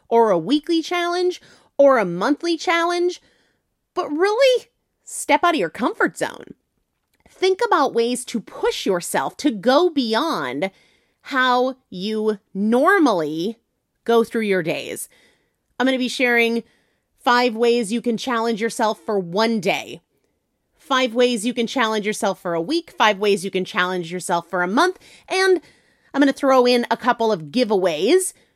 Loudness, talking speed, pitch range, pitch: -20 LUFS, 150 wpm, 215-300 Hz, 245 Hz